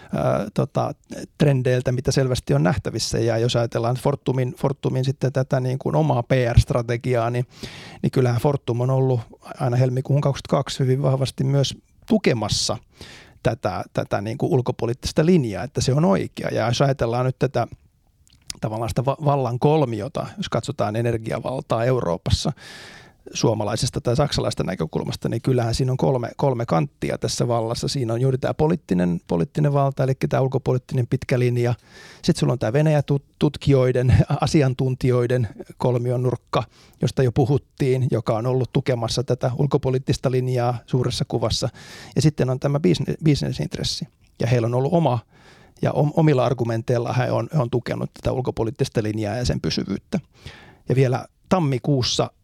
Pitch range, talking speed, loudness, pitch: 120-140 Hz, 145 wpm, -22 LUFS, 130 Hz